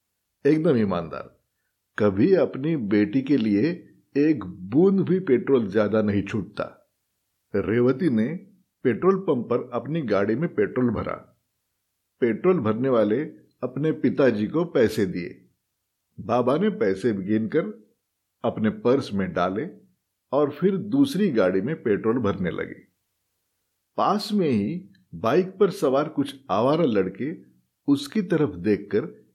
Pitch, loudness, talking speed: 130 Hz, -24 LUFS, 125 wpm